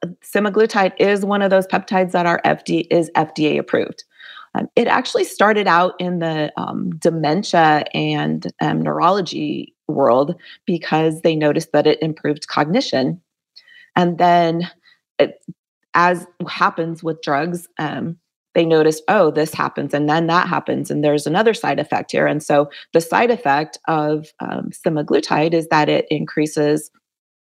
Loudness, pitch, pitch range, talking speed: -18 LUFS, 165 Hz, 150-180 Hz, 145 wpm